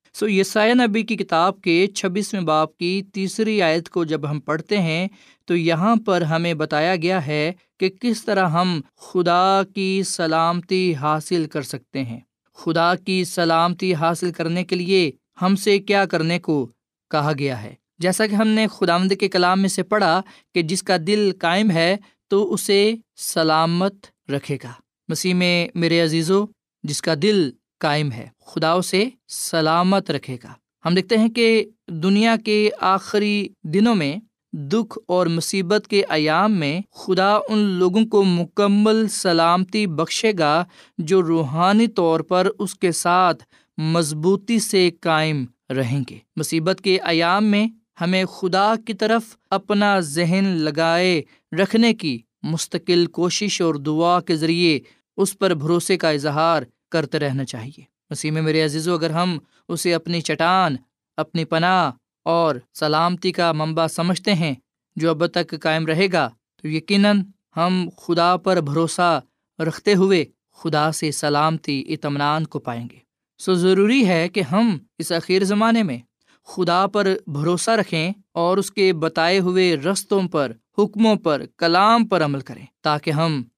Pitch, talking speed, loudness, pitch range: 175 Hz, 150 wpm, -20 LUFS, 160-195 Hz